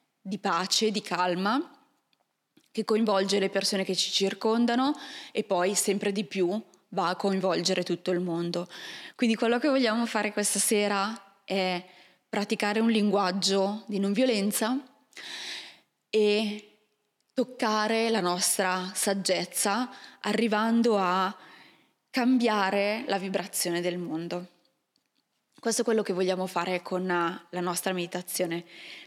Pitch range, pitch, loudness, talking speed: 185-220 Hz, 200 Hz, -27 LUFS, 120 wpm